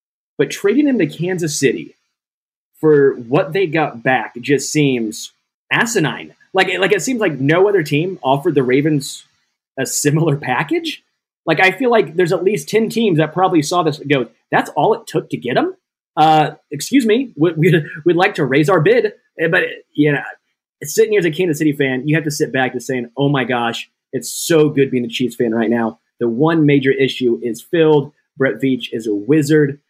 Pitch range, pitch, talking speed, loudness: 135-185 Hz, 155 Hz, 205 wpm, -16 LUFS